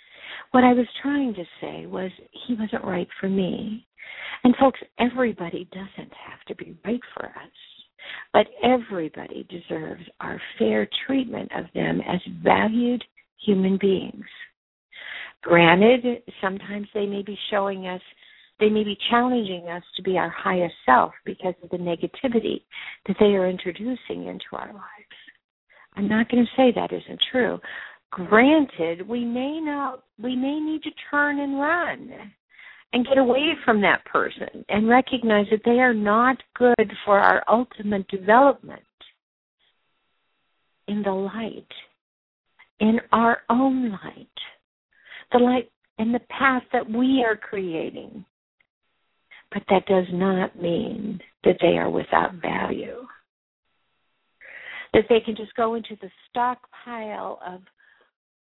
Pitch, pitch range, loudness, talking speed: 220 Hz, 195-250 Hz, -22 LUFS, 135 wpm